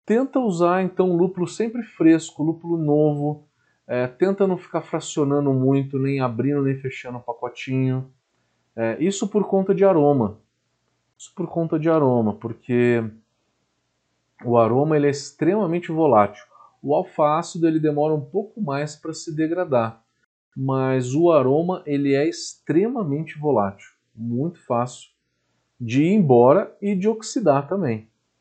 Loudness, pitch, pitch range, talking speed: -21 LUFS, 145 Hz, 120-170 Hz, 135 wpm